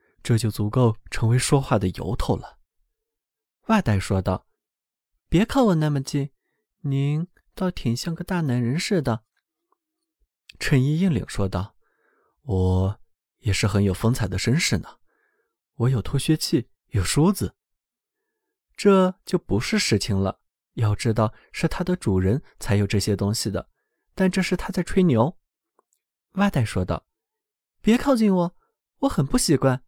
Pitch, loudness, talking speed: 140 Hz, -23 LUFS, 200 characters per minute